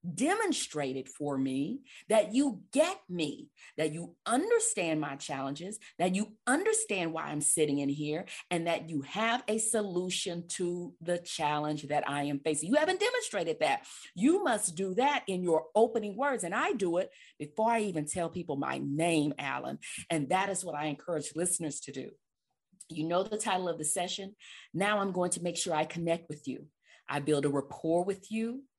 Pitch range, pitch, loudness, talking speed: 150-210 Hz, 175 Hz, -32 LUFS, 185 wpm